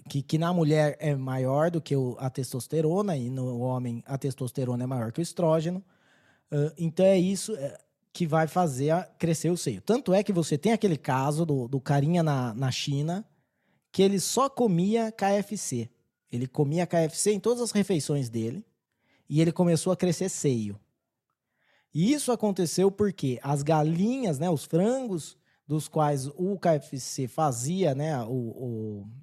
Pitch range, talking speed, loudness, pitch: 135-180 Hz, 165 wpm, -27 LUFS, 160 Hz